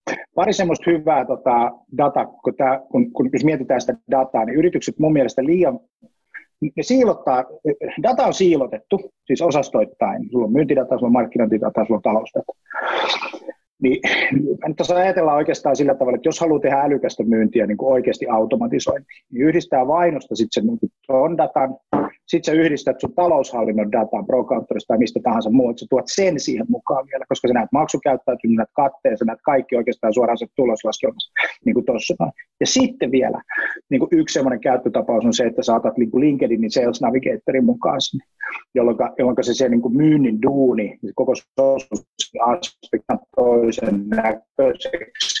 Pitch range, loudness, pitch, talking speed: 120-180 Hz, -19 LUFS, 140 Hz, 160 wpm